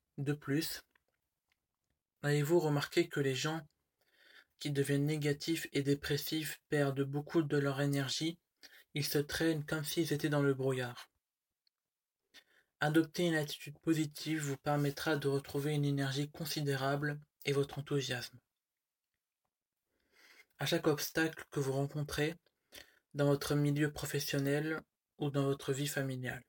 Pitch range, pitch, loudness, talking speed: 140-155 Hz, 145 Hz, -35 LUFS, 125 wpm